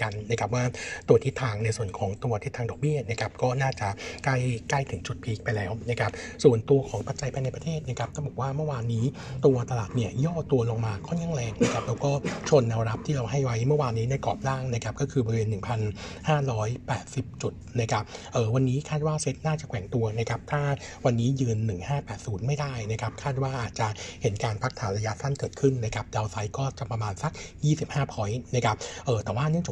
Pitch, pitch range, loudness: 120 Hz, 110-135 Hz, -28 LUFS